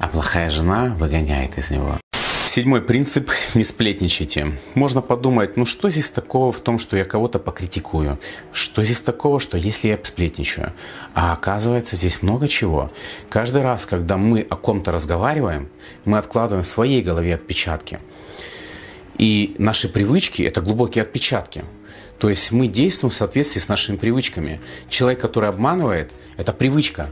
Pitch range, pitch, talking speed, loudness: 85-120 Hz, 105 Hz, 150 wpm, -19 LUFS